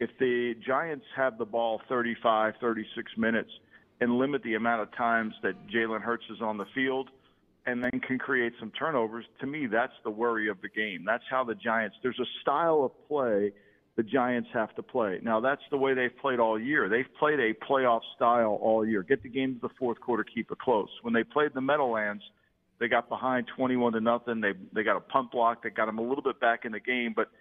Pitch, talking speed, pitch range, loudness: 115 Hz, 225 wpm, 110-125 Hz, -29 LUFS